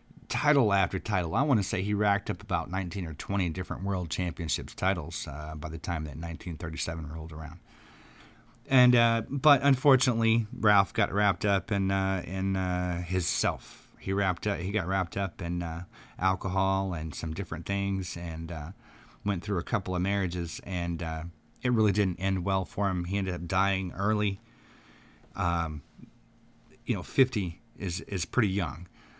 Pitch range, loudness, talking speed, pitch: 85-105 Hz, -29 LUFS, 175 wpm, 95 Hz